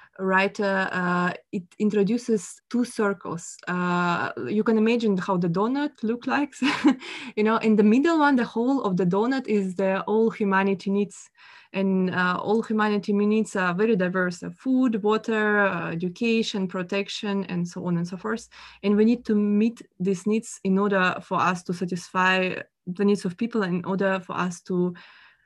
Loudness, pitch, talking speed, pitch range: -24 LUFS, 205 Hz, 170 wpm, 185-225 Hz